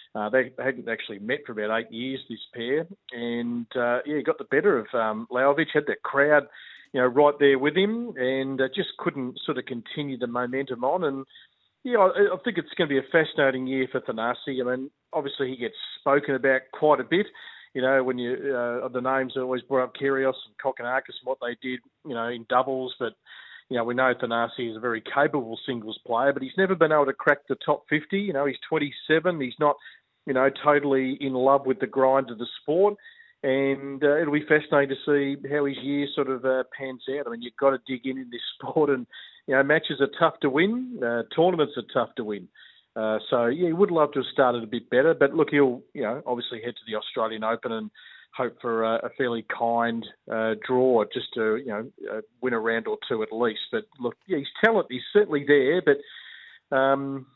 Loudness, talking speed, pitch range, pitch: -25 LUFS, 230 wpm, 125-145 Hz, 135 Hz